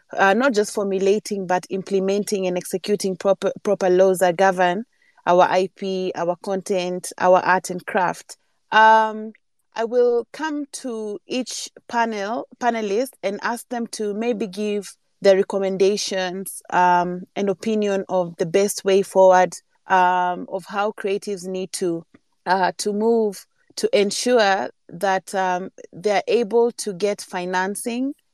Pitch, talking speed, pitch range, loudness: 195 Hz, 135 wpm, 185-215 Hz, -21 LUFS